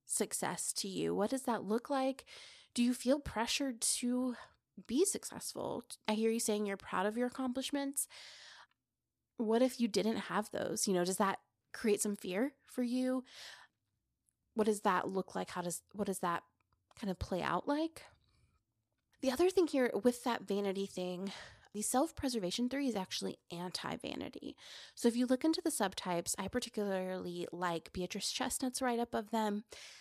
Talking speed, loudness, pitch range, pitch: 165 wpm, -36 LUFS, 195-255 Hz, 225 Hz